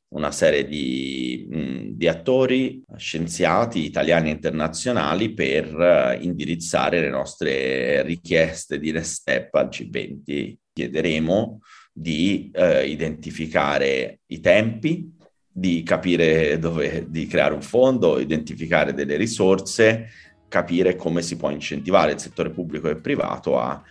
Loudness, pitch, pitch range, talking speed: -22 LUFS, 85 Hz, 80-100 Hz, 115 wpm